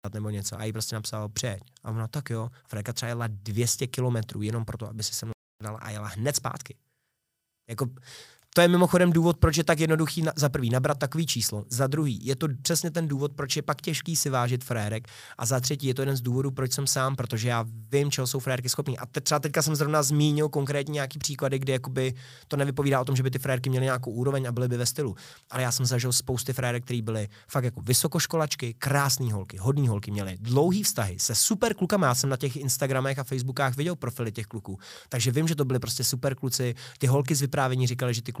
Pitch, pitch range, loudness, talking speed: 130 Hz, 120-145 Hz, -27 LUFS, 230 wpm